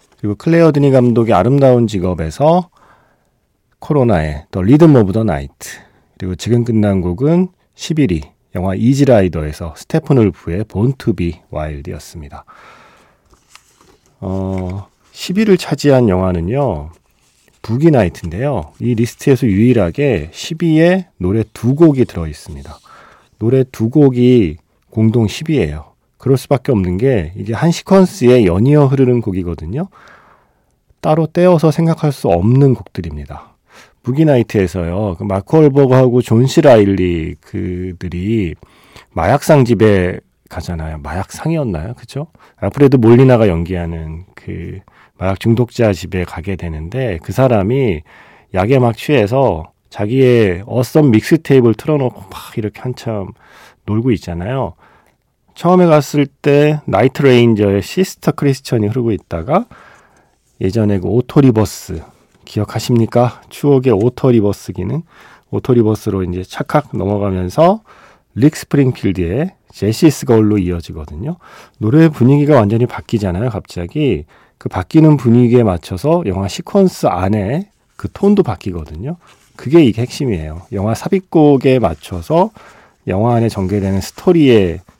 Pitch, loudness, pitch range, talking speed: 115 Hz, -13 LUFS, 95-140 Hz, 300 characters per minute